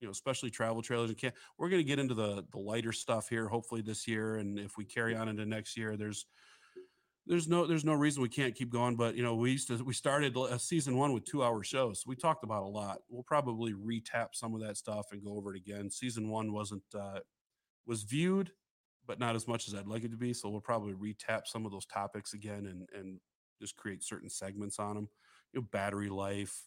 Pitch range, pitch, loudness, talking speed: 105-125 Hz, 115 Hz, -37 LUFS, 245 wpm